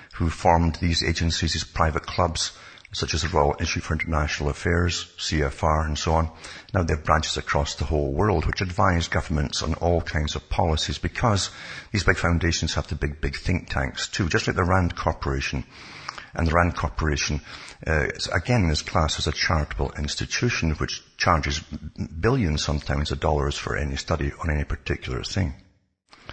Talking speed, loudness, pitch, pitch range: 175 wpm, -24 LUFS, 80 Hz, 75-90 Hz